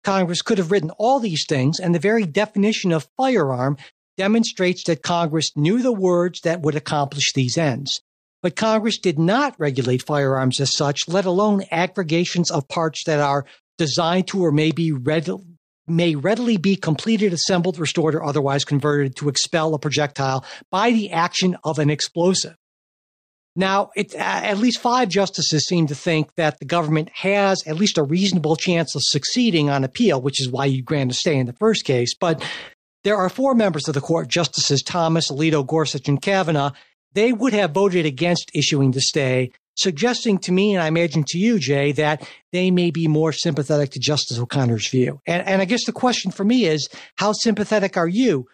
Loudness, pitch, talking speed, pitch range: -20 LUFS, 165 Hz, 185 wpm, 150-195 Hz